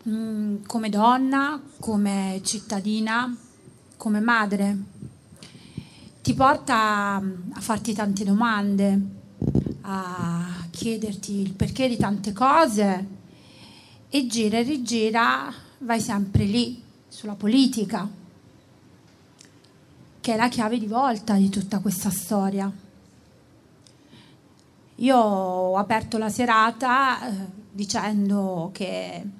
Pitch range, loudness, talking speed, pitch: 200-235 Hz, -24 LUFS, 100 wpm, 215 Hz